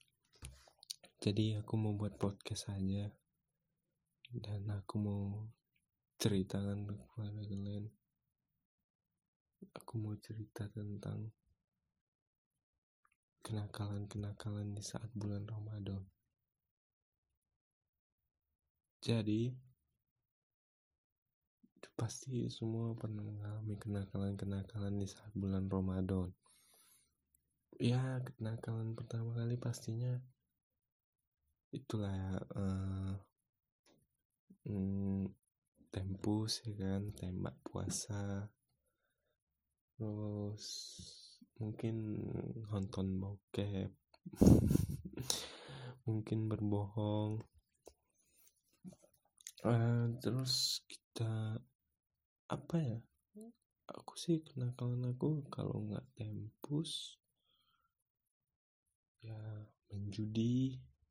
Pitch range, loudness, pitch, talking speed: 100-120 Hz, -41 LUFS, 105 Hz, 60 wpm